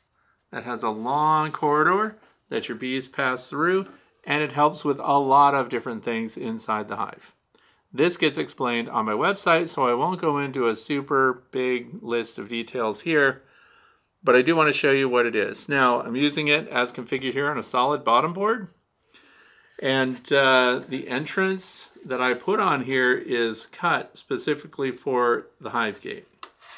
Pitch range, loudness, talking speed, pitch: 125-150 Hz, -23 LUFS, 175 wpm, 135 Hz